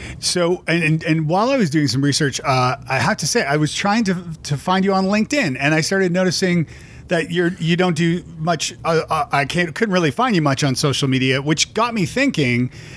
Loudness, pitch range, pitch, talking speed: -18 LUFS, 145-185 Hz, 165 Hz, 230 wpm